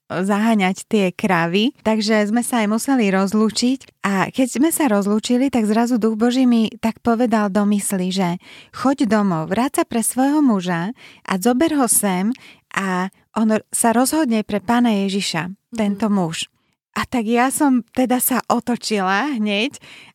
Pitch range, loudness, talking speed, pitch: 200-245 Hz, -18 LUFS, 150 wpm, 220 Hz